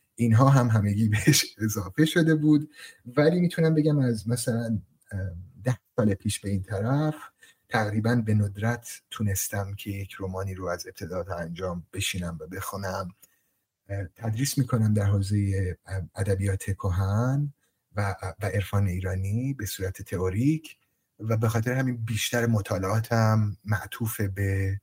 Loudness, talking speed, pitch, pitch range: -27 LUFS, 135 wpm, 105 Hz, 95-120 Hz